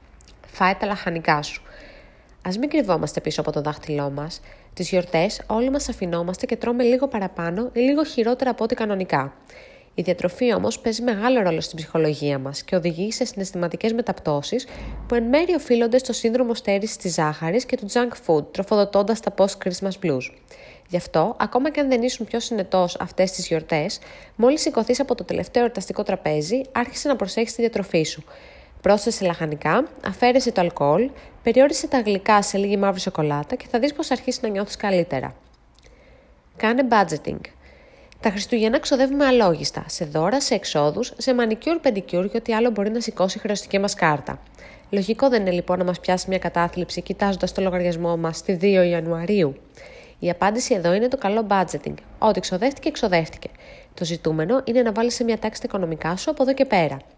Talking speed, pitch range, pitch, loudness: 175 wpm, 170-240 Hz, 200 Hz, -22 LUFS